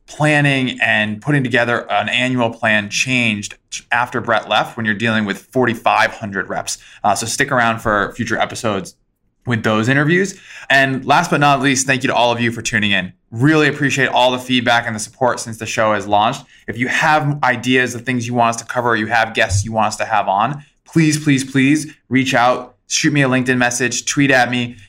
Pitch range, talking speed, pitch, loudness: 115-135 Hz, 210 wpm, 125 Hz, -16 LUFS